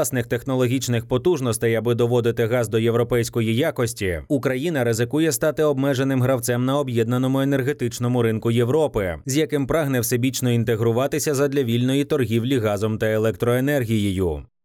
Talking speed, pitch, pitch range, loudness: 125 wpm, 125 Hz, 115-140 Hz, -21 LUFS